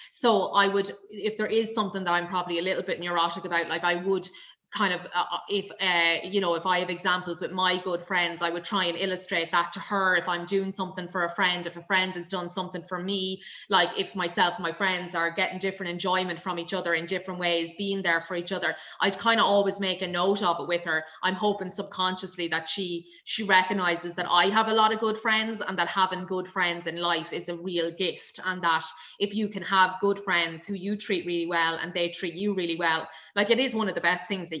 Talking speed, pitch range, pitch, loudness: 245 wpm, 175-195 Hz, 185 Hz, -26 LUFS